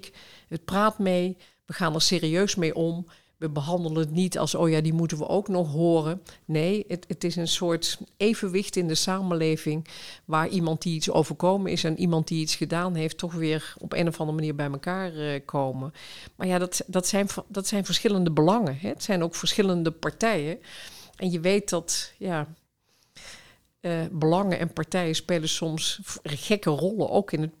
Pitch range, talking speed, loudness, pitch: 160-185 Hz, 185 wpm, -26 LUFS, 170 Hz